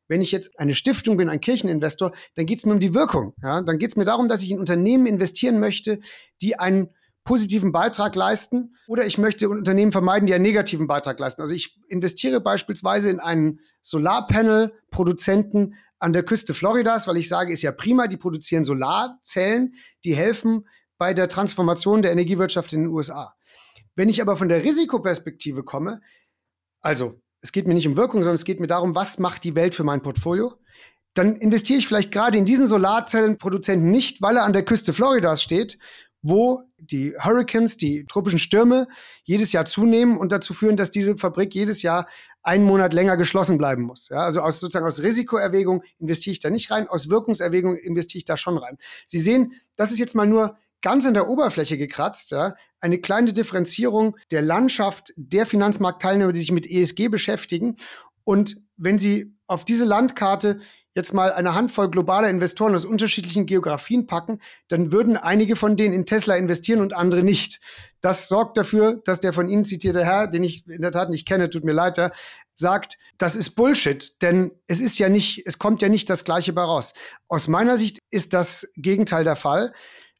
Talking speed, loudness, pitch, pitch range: 190 wpm, -21 LUFS, 195 Hz, 175-215 Hz